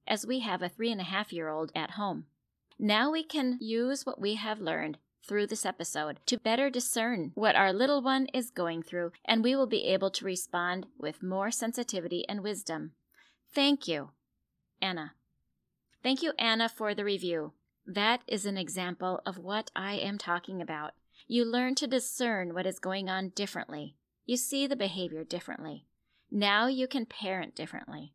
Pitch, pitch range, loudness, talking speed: 205 Hz, 180-245 Hz, -32 LUFS, 175 wpm